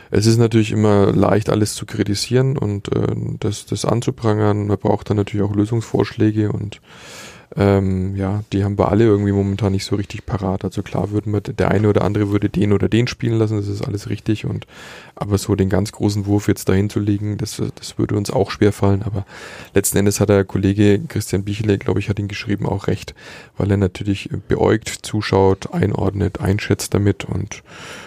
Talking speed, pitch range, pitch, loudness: 195 wpm, 100-110 Hz, 105 Hz, -19 LUFS